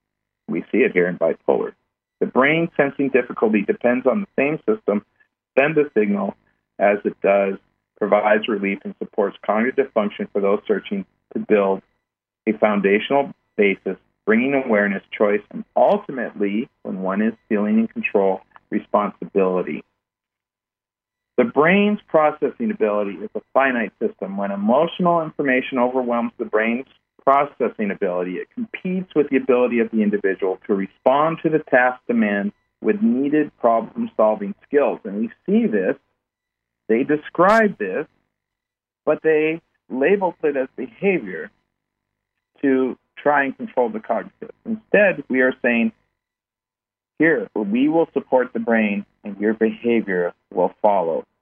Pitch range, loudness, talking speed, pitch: 105-155 Hz, -20 LUFS, 135 wpm, 125 Hz